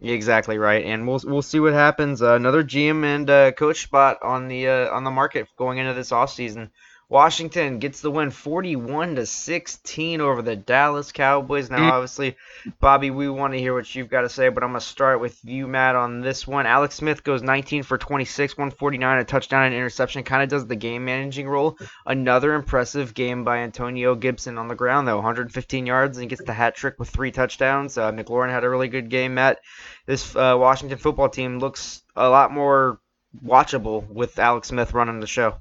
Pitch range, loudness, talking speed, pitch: 125-140 Hz, -21 LUFS, 205 wpm, 130 Hz